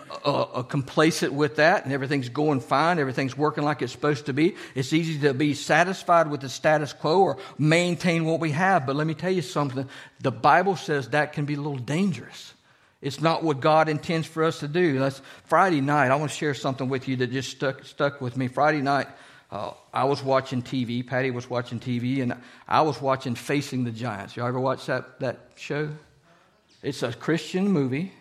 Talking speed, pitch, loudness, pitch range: 210 wpm, 145 Hz, -25 LUFS, 135-155 Hz